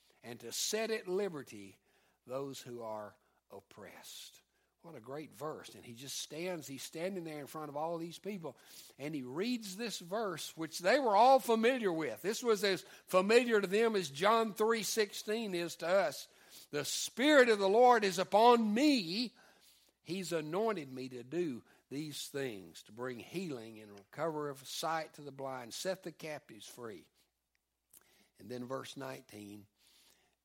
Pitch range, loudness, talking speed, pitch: 130-210 Hz, -34 LUFS, 160 wpm, 165 Hz